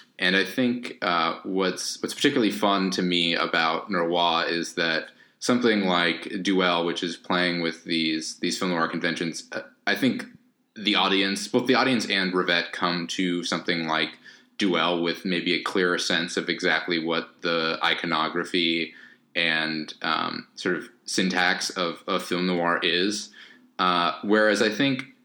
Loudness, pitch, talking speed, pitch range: -24 LUFS, 90 Hz, 150 wpm, 85-95 Hz